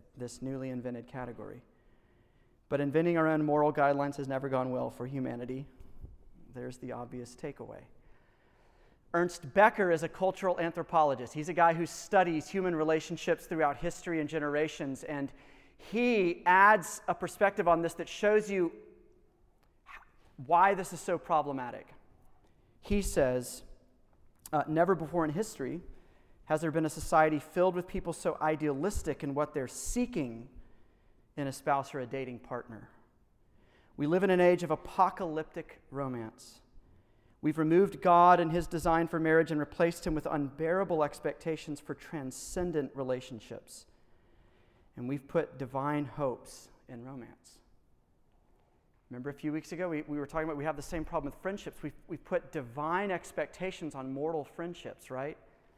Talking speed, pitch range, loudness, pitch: 150 wpm, 135-175 Hz, -31 LUFS, 155 Hz